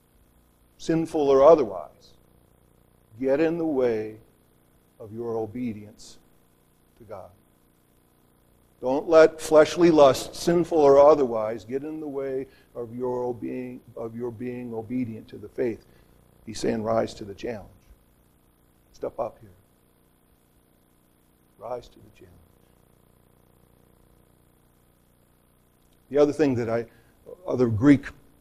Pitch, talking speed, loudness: 120 Hz, 110 wpm, -23 LUFS